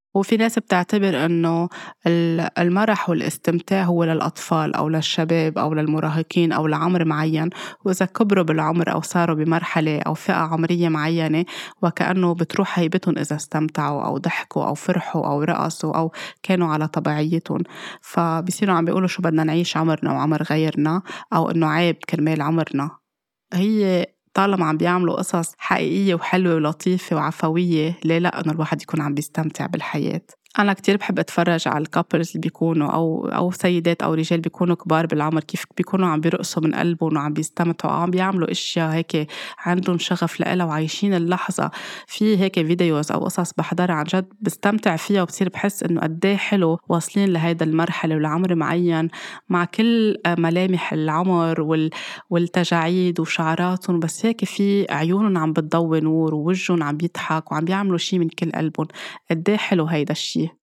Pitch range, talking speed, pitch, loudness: 160-180 Hz, 150 wpm, 170 Hz, -21 LUFS